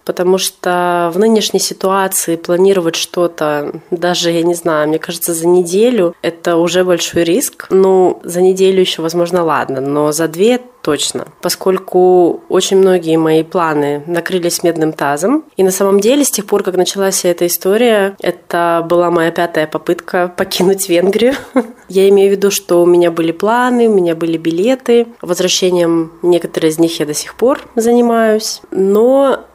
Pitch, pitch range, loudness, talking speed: 180 Hz, 170-195 Hz, -12 LUFS, 160 wpm